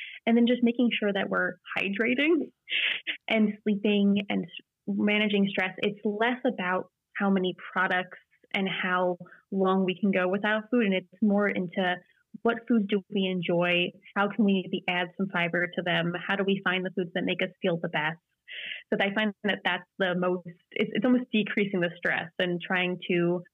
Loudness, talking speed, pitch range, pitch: -27 LUFS, 185 wpm, 180-210 Hz, 190 Hz